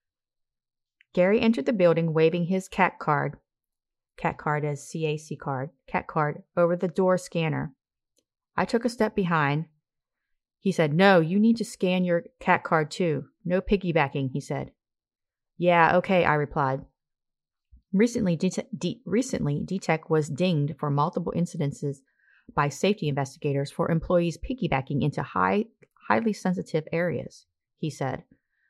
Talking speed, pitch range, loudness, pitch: 135 wpm, 145-185 Hz, -26 LUFS, 165 Hz